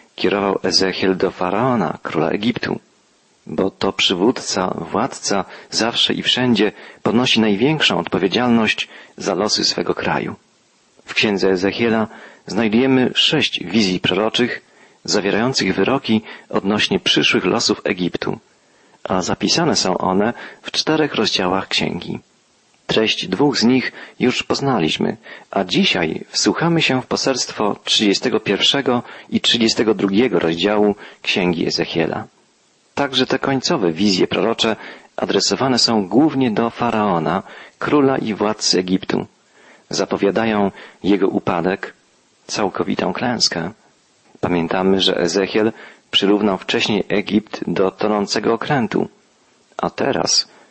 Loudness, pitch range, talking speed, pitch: -18 LUFS, 100-125 Hz, 105 wpm, 110 Hz